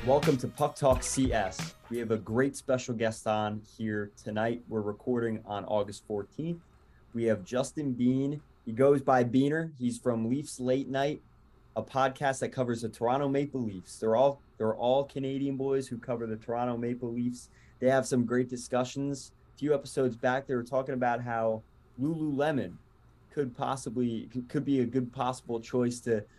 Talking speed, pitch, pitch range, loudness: 175 wpm, 125 Hz, 115-135 Hz, -31 LUFS